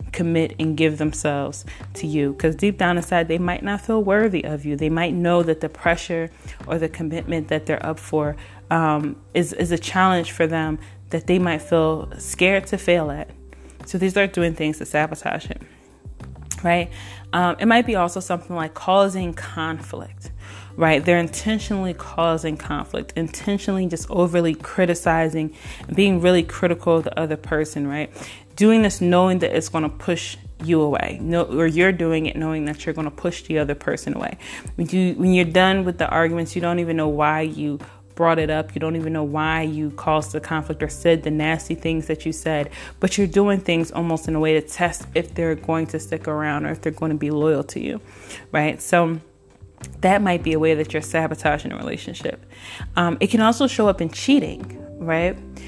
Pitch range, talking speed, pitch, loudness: 150-175 Hz, 200 wpm, 160 Hz, -21 LUFS